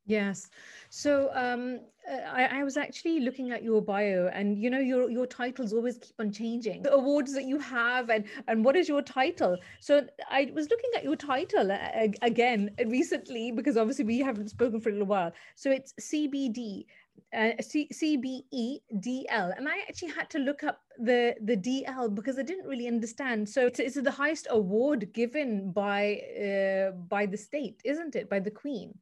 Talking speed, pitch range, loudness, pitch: 180 wpm, 220-280 Hz, -30 LUFS, 245 Hz